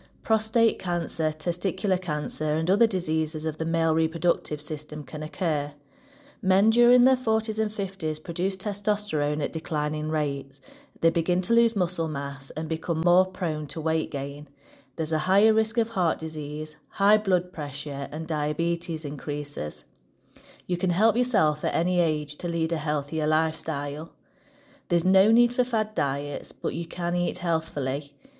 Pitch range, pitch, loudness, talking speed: 150-195 Hz, 165 Hz, -26 LUFS, 155 wpm